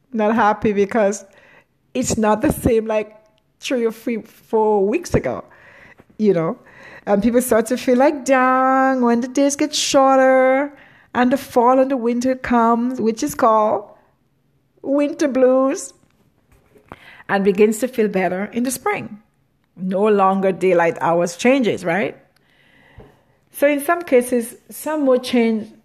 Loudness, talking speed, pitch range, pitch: -18 LUFS, 140 wpm, 215-265 Hz, 240 Hz